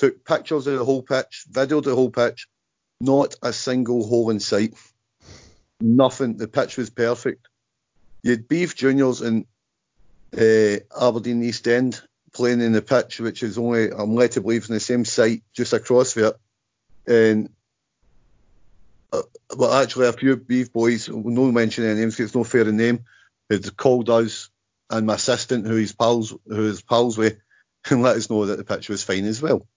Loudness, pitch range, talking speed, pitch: -21 LUFS, 110-125 Hz, 175 wpm, 115 Hz